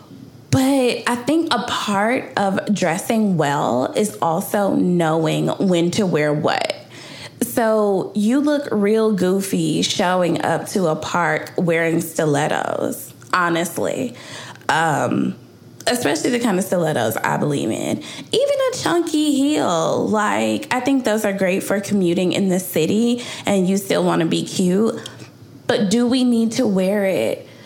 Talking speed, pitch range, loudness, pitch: 140 wpm, 175-240 Hz, -19 LUFS, 200 Hz